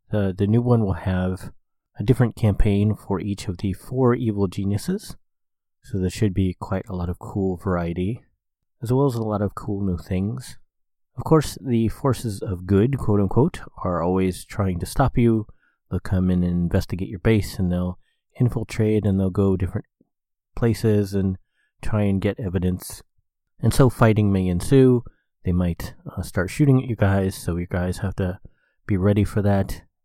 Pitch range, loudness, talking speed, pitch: 95-115 Hz, -22 LUFS, 180 wpm, 100 Hz